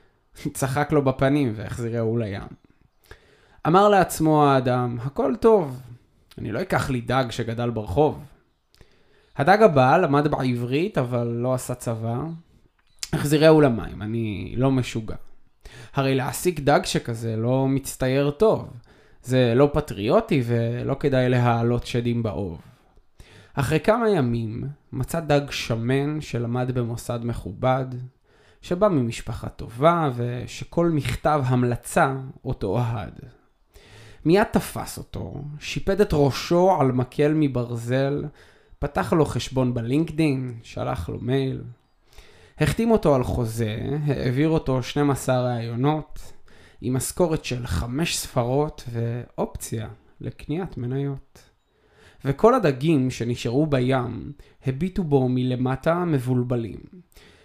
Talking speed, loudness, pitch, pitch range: 105 wpm, -23 LUFS, 130 Hz, 120-150 Hz